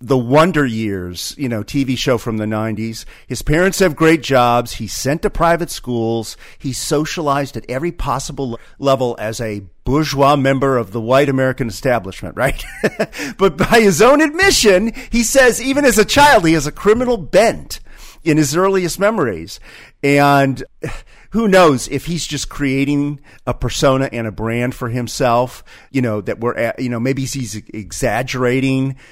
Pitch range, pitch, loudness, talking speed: 120-160 Hz, 135 Hz, -16 LUFS, 165 wpm